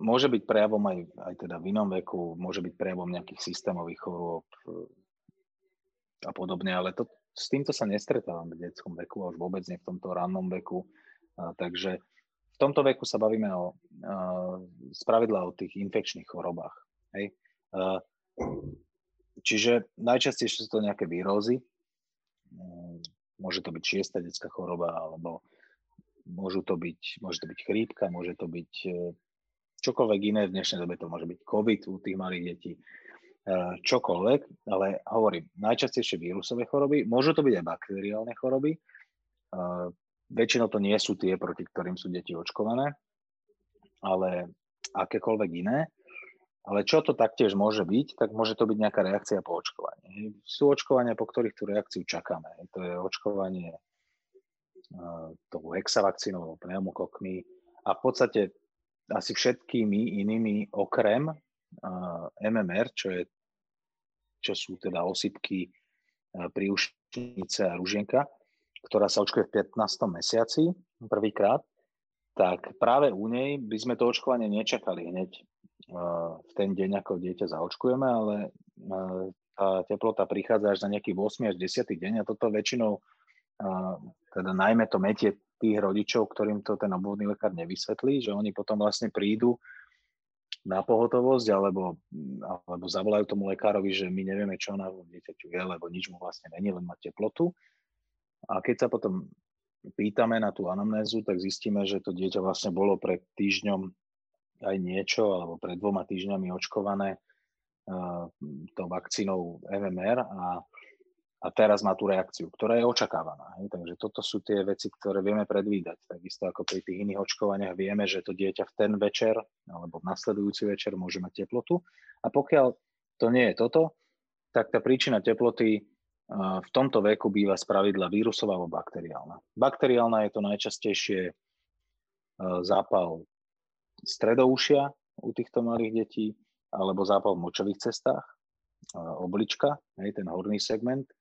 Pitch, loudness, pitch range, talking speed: 100 Hz, -29 LUFS, 90-115 Hz, 145 wpm